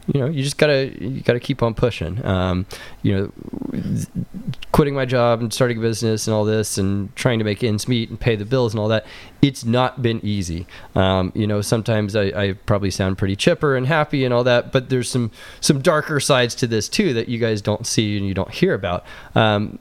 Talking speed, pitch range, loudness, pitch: 225 wpm, 105-130 Hz, -20 LUFS, 115 Hz